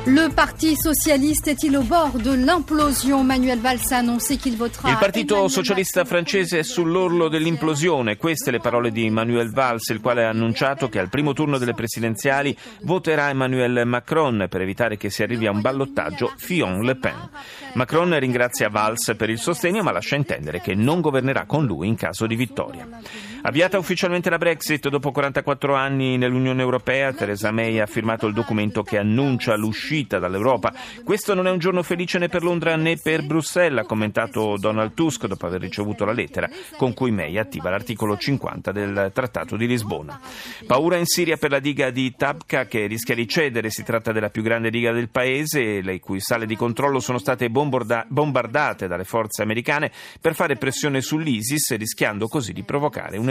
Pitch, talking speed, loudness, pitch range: 130 Hz, 175 wpm, -21 LUFS, 115-165 Hz